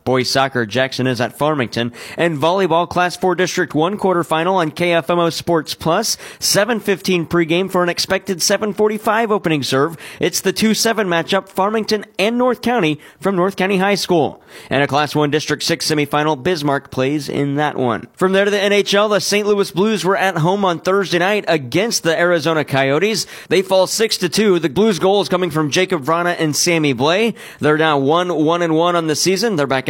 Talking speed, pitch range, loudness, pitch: 190 wpm, 150-195 Hz, -16 LUFS, 175 Hz